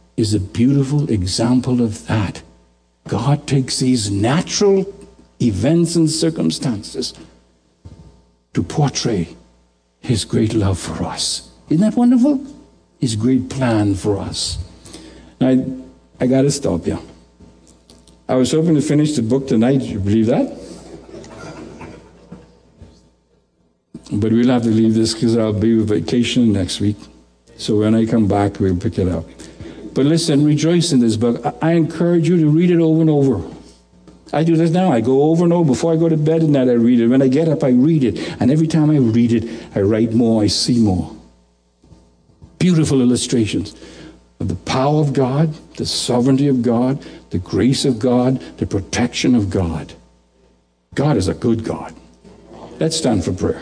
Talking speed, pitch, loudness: 170 wpm, 115 Hz, -16 LUFS